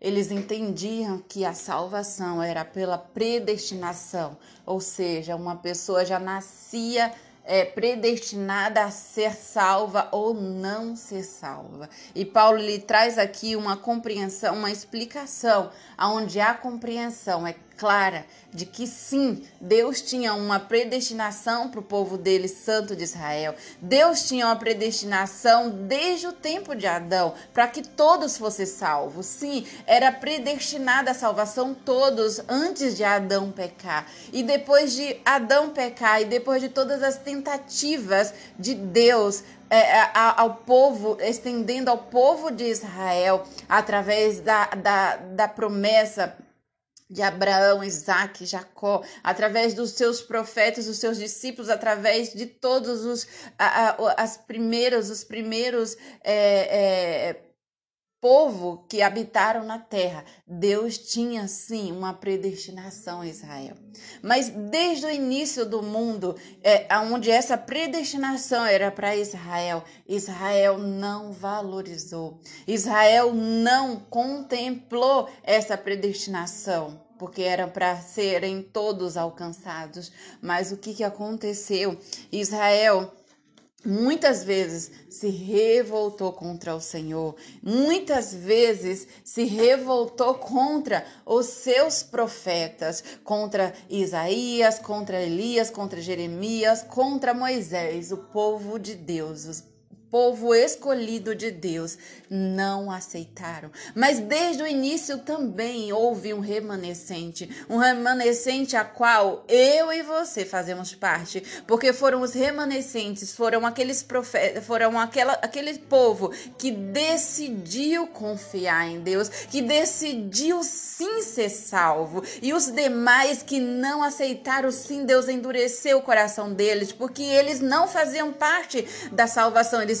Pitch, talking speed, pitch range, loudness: 220 Hz, 120 wpm, 195-250 Hz, -24 LUFS